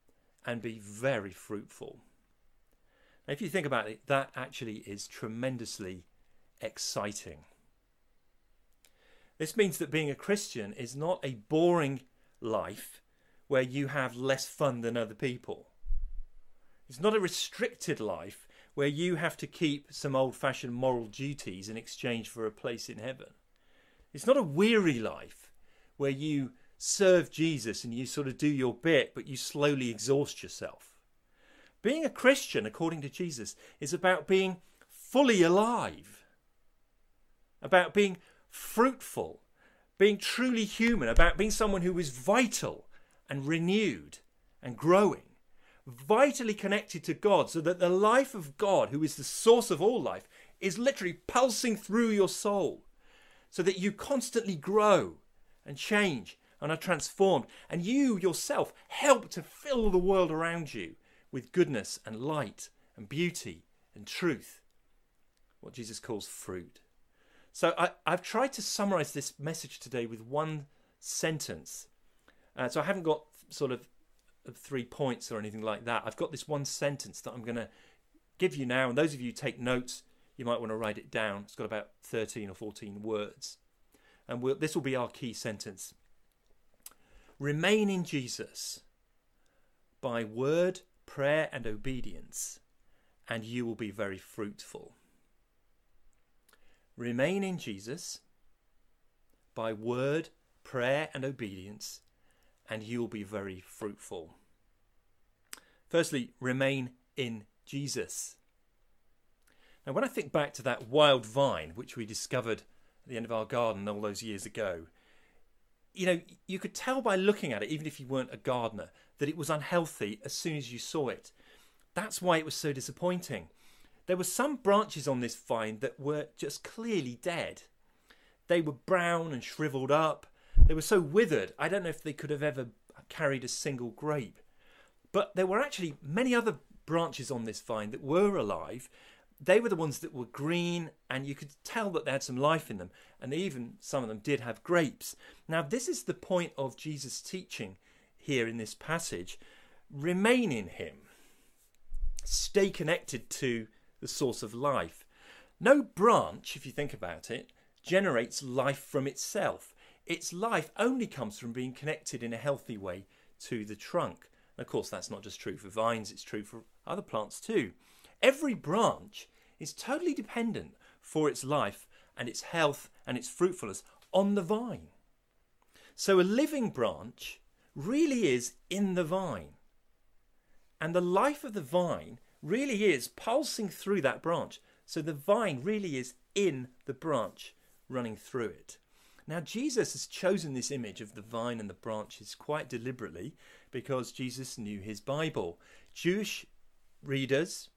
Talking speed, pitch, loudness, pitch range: 155 wpm, 145 Hz, -32 LUFS, 120-185 Hz